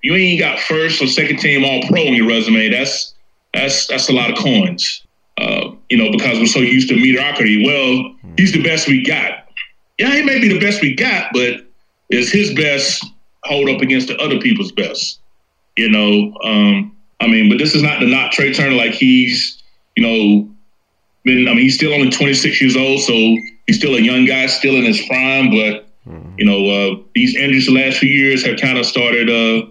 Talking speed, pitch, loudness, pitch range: 210 wpm, 130 Hz, -13 LUFS, 120-175 Hz